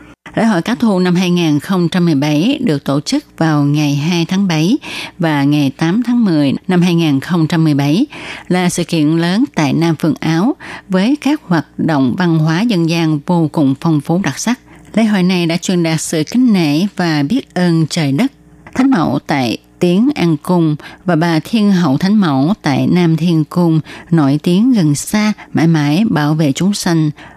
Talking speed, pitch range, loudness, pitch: 180 wpm, 155-200 Hz, -14 LUFS, 170 Hz